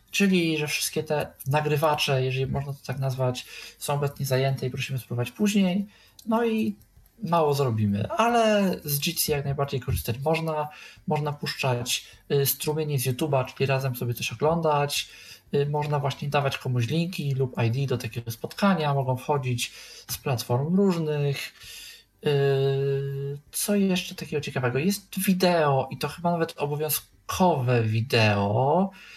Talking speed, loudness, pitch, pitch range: 140 wpm, -26 LUFS, 145 Hz, 130-160 Hz